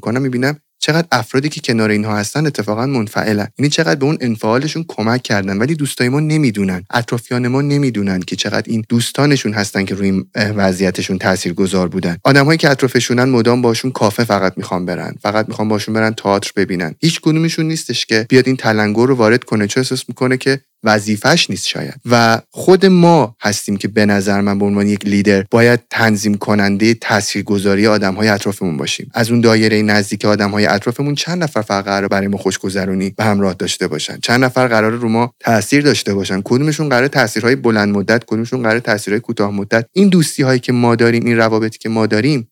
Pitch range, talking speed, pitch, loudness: 100-130 Hz, 190 wpm, 110 Hz, -14 LUFS